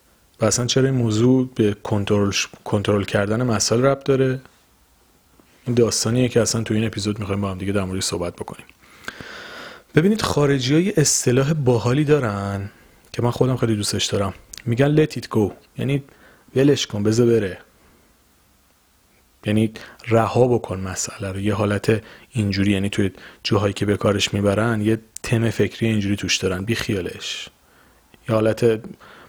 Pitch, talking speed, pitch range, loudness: 110 Hz, 150 wpm, 100-120 Hz, -20 LUFS